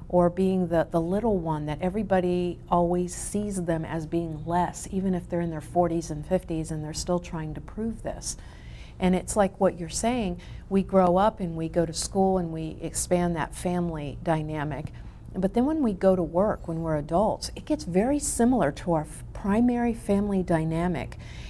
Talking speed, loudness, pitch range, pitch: 195 wpm, -27 LUFS, 165-195 Hz, 175 Hz